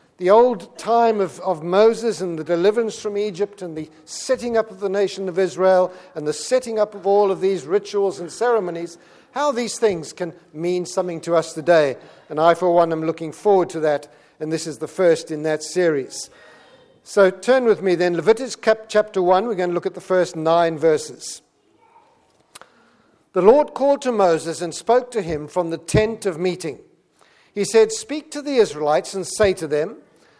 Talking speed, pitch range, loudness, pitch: 195 wpm, 165-220 Hz, -20 LUFS, 185 Hz